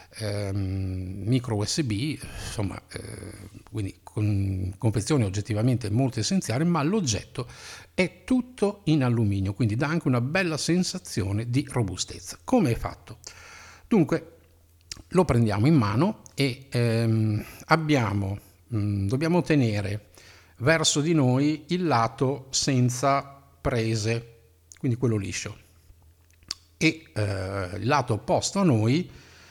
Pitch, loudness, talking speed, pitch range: 115 Hz, -26 LUFS, 115 wpm, 100-140 Hz